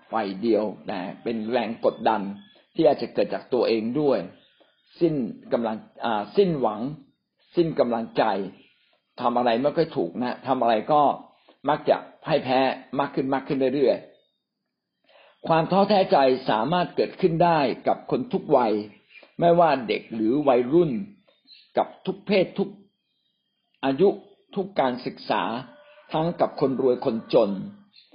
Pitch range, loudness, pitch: 125-195 Hz, -24 LUFS, 145 Hz